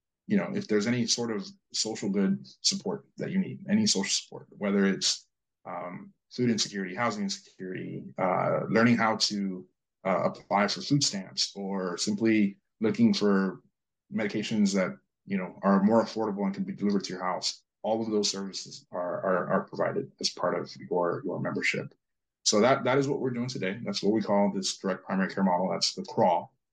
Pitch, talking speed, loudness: 115 Hz, 190 wpm, -28 LUFS